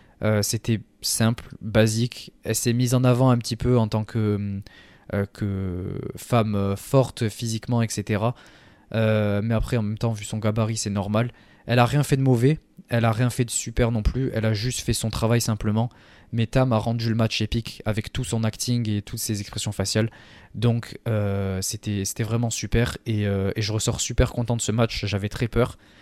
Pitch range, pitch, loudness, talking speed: 105-120 Hz, 110 Hz, -24 LUFS, 205 wpm